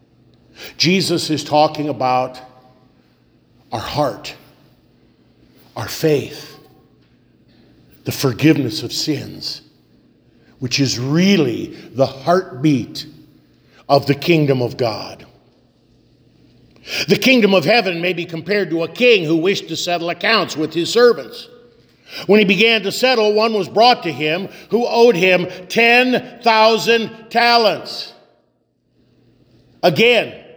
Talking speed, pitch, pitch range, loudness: 110 wpm, 165 Hz, 135-215 Hz, -16 LUFS